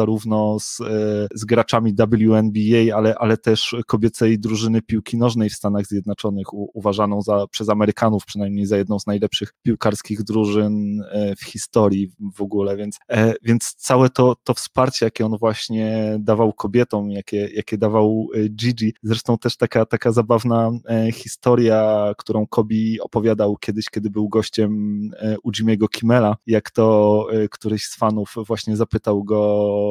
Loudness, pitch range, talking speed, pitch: -19 LUFS, 105-115 Hz, 140 wpm, 110 Hz